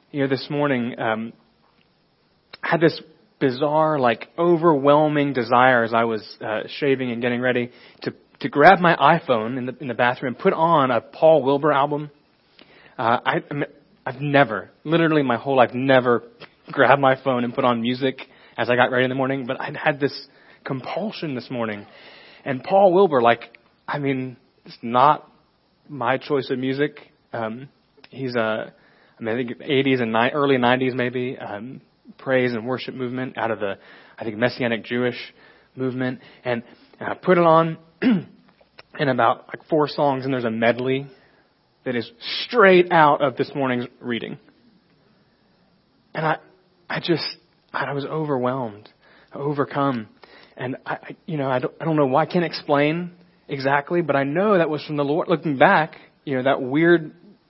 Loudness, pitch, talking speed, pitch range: -21 LUFS, 135 Hz, 170 wpm, 125-150 Hz